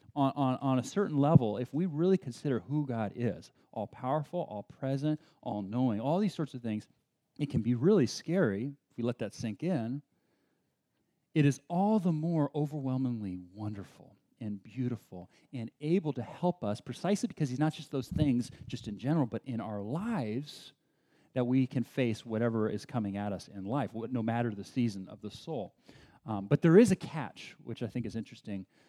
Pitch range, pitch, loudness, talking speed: 115-155 Hz, 130 Hz, -33 LUFS, 195 wpm